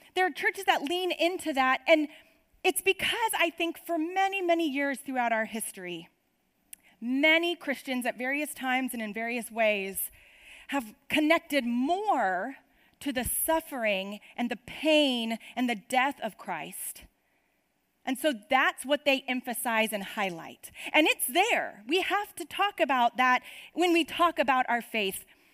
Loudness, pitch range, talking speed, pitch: -28 LUFS, 240-335 Hz, 155 wpm, 280 Hz